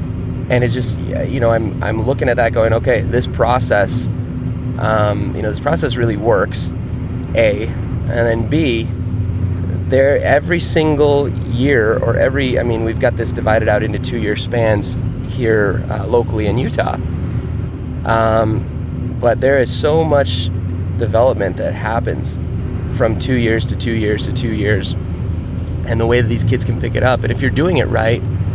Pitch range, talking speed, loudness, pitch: 105-120 Hz, 170 wpm, -16 LUFS, 115 Hz